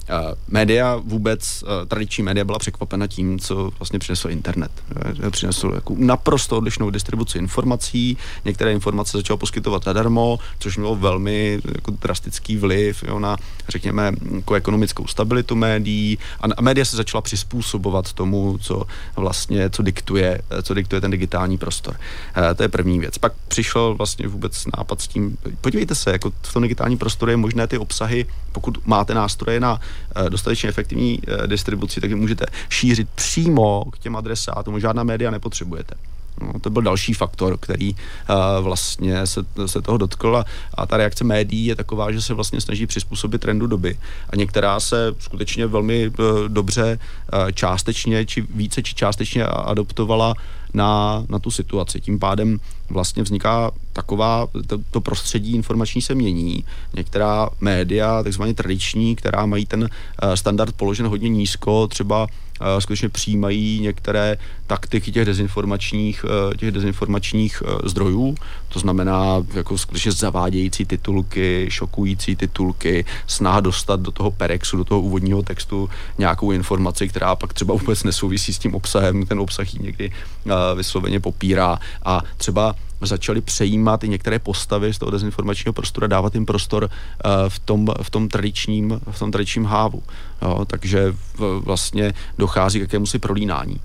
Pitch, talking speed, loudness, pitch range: 105 Hz, 155 wpm, -21 LUFS, 95-110 Hz